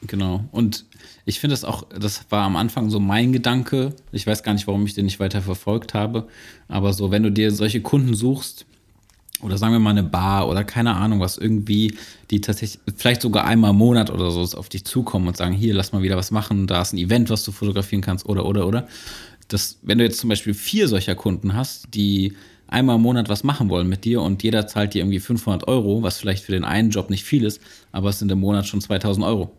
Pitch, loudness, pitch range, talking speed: 105 Hz, -21 LUFS, 100-115 Hz, 235 wpm